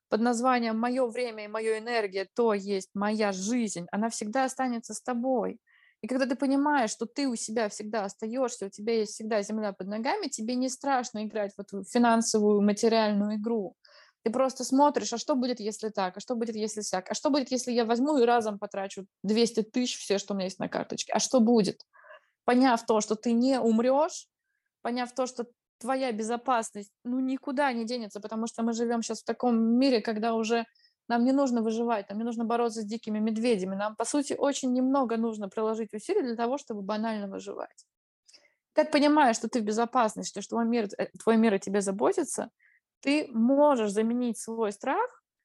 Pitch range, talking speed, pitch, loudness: 215-255 Hz, 190 wpm, 230 Hz, -28 LUFS